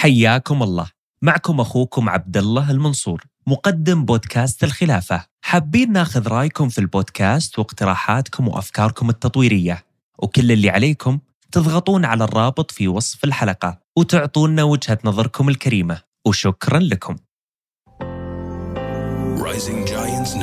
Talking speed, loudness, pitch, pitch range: 95 wpm, -18 LUFS, 120 Hz, 100-145 Hz